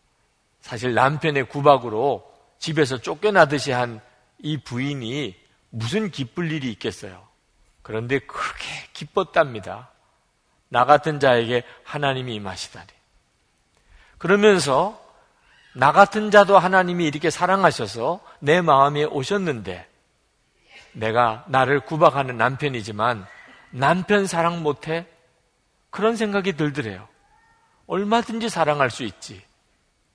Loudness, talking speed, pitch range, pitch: -21 LUFS, 250 characters per minute, 125-175 Hz, 145 Hz